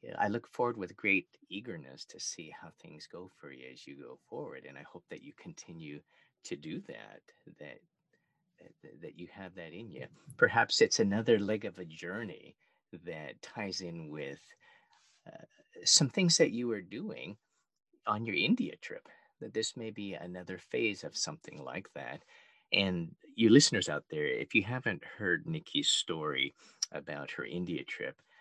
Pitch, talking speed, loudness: 110 Hz, 170 wpm, -32 LUFS